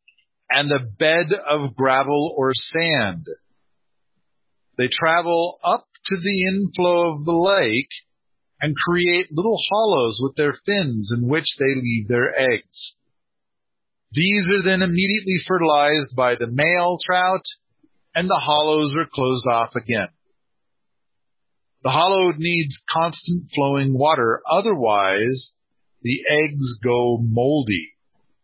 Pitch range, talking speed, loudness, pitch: 130-175 Hz, 120 wpm, -19 LUFS, 155 Hz